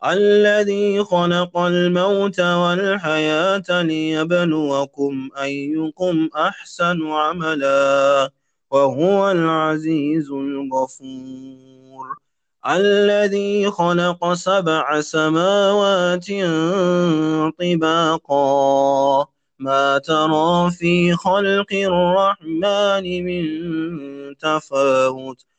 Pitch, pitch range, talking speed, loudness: 160 Hz, 140-185 Hz, 55 wpm, -18 LUFS